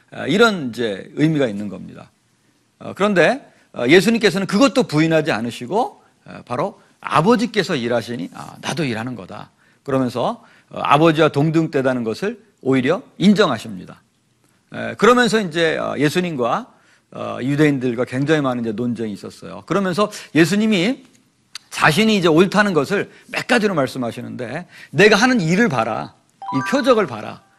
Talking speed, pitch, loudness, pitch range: 310 characters per minute, 160 Hz, -18 LUFS, 130-210 Hz